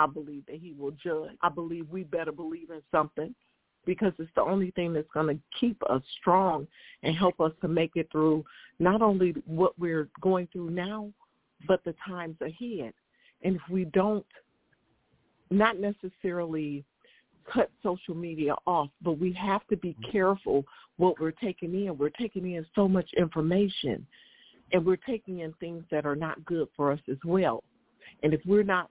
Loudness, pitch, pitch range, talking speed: -29 LUFS, 175 Hz, 160-190 Hz, 175 wpm